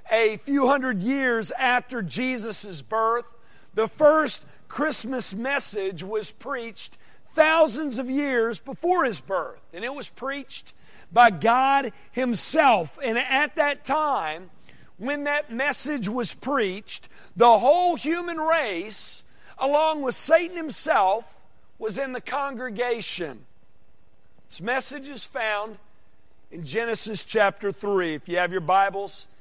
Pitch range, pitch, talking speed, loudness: 205-280 Hz, 240 Hz, 120 wpm, -24 LUFS